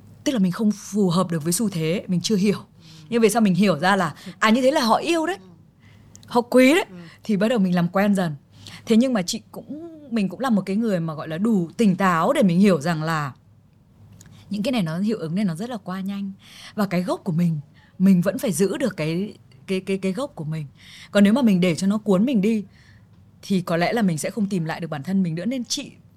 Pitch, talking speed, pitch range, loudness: 195 Hz, 260 wpm, 170-220 Hz, -22 LUFS